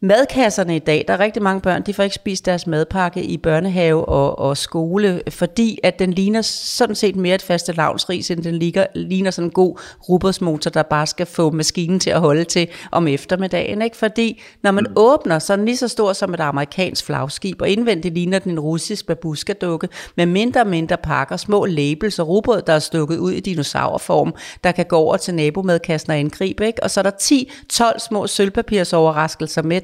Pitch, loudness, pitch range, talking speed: 180 Hz, -18 LUFS, 165-200 Hz, 210 wpm